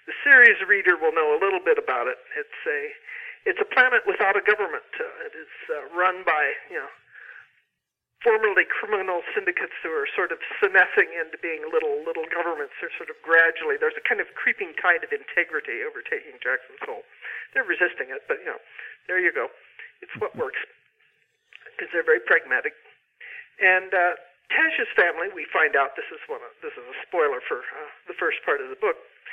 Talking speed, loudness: 190 wpm, -22 LUFS